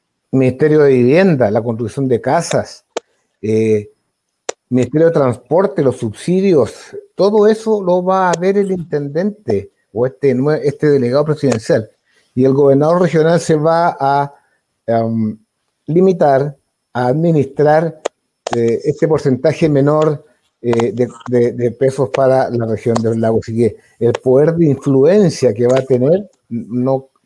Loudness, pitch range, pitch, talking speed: -14 LUFS, 120-160 Hz, 135 Hz, 135 wpm